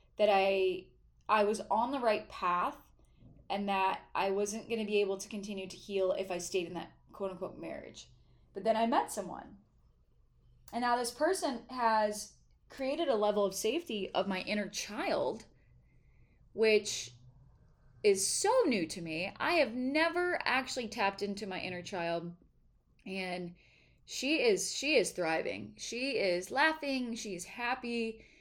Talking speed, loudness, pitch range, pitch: 155 wpm, -33 LUFS, 185-245 Hz, 210 Hz